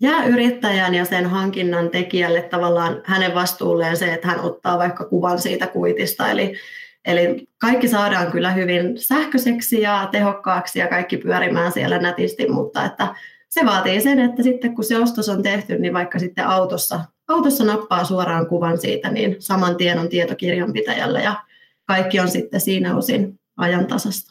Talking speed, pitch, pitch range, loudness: 160 wpm, 190 Hz, 180-235 Hz, -19 LUFS